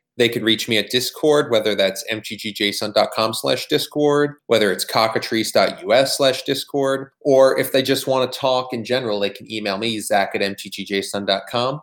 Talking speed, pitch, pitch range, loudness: 160 wpm, 120 Hz, 105-135 Hz, -19 LUFS